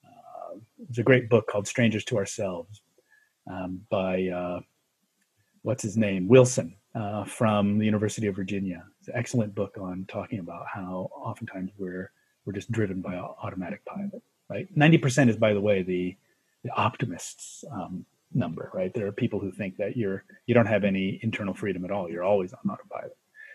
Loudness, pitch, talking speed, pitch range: -27 LUFS, 105 Hz, 180 wpm, 95-120 Hz